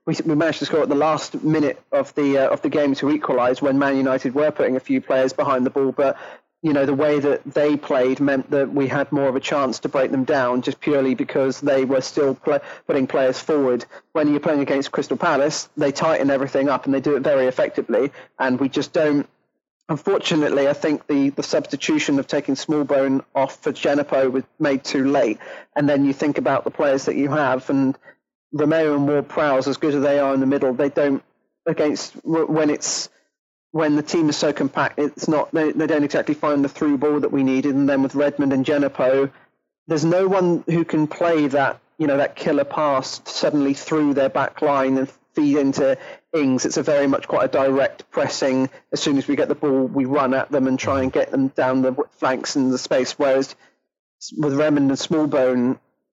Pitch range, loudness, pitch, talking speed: 135-150 Hz, -20 LUFS, 140 Hz, 215 wpm